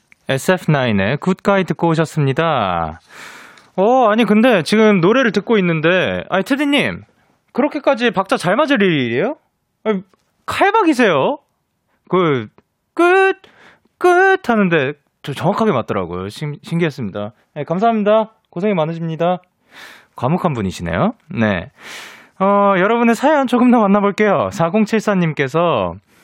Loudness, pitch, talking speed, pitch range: -16 LUFS, 195 Hz, 265 characters per minute, 155-230 Hz